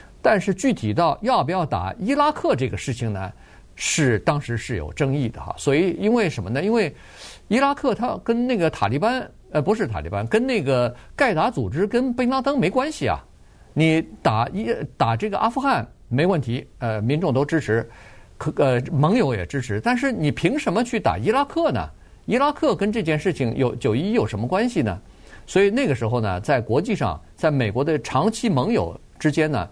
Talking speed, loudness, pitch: 290 characters per minute, -22 LUFS, 160 Hz